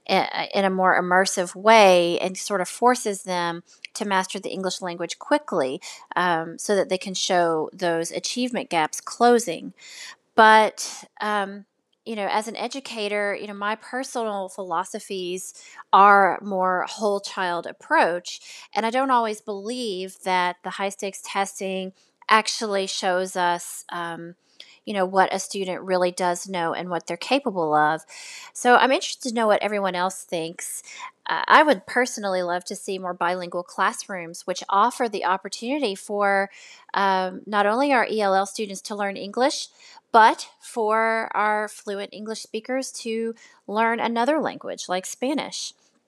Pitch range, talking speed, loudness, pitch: 185-225 Hz, 150 wpm, -23 LUFS, 200 Hz